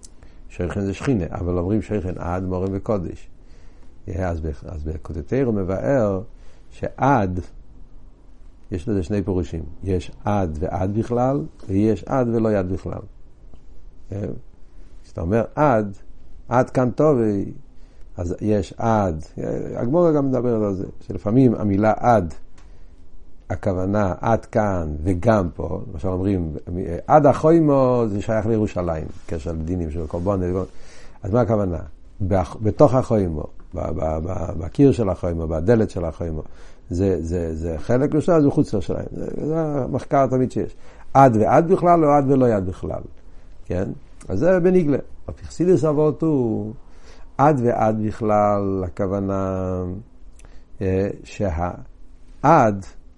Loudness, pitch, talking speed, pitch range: -21 LUFS, 95 Hz, 120 wpm, 85-115 Hz